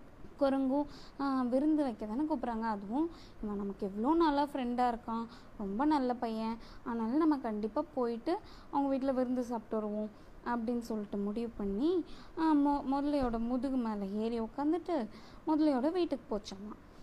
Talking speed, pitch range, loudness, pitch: 125 wpm, 225-290 Hz, -34 LUFS, 255 Hz